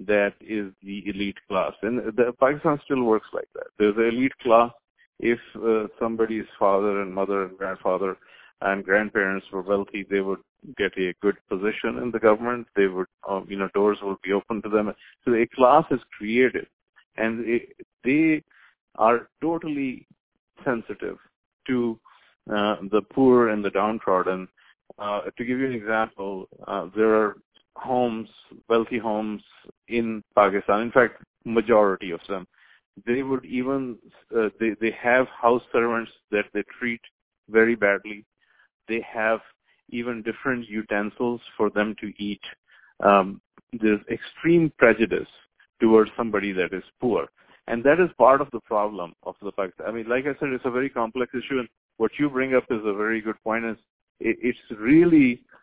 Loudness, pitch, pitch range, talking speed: -24 LUFS, 115 Hz, 105-125 Hz, 165 wpm